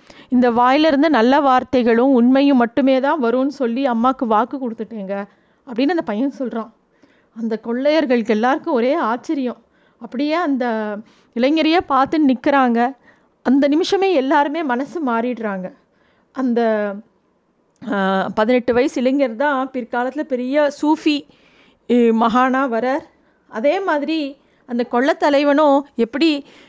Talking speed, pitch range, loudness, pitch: 105 wpm, 235-290 Hz, -17 LUFS, 260 Hz